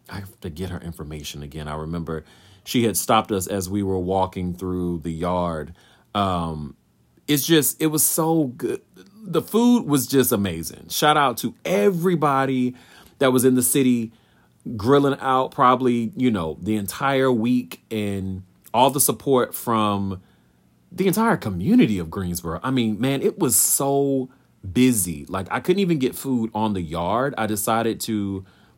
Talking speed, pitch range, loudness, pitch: 165 wpm, 90-135 Hz, -21 LUFS, 110 Hz